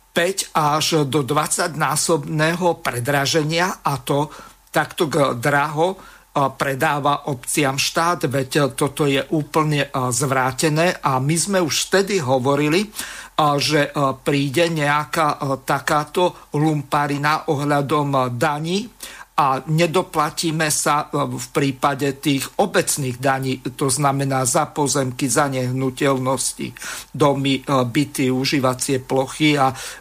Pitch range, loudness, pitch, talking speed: 135-160 Hz, -19 LUFS, 145 Hz, 100 wpm